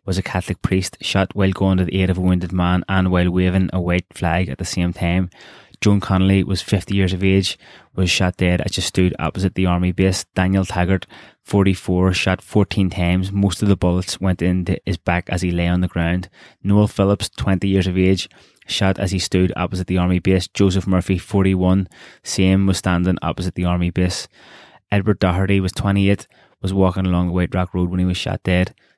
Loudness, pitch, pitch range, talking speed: -19 LUFS, 95 Hz, 90-95 Hz, 210 wpm